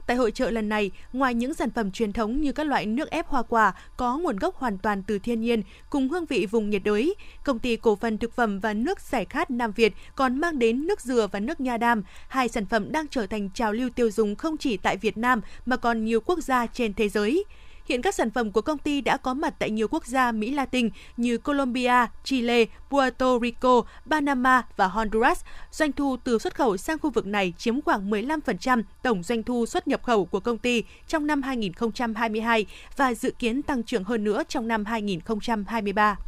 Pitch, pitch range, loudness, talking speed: 240 Hz, 225-270 Hz, -25 LUFS, 220 wpm